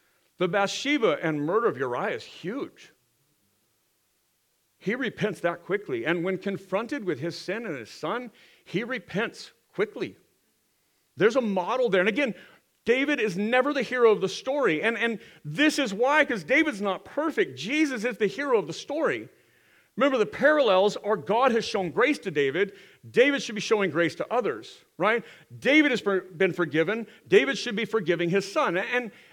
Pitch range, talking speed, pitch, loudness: 190-270 Hz, 175 wpm, 220 Hz, -26 LUFS